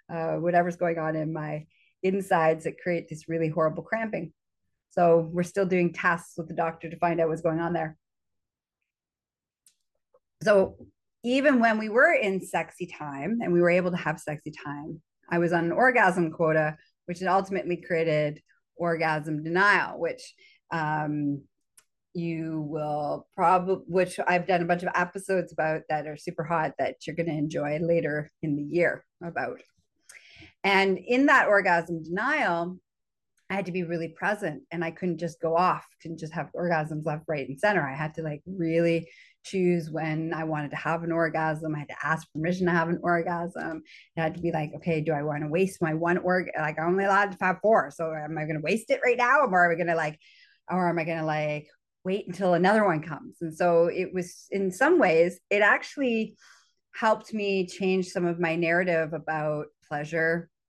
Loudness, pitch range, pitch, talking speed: -26 LUFS, 160-185 Hz, 170 Hz, 195 wpm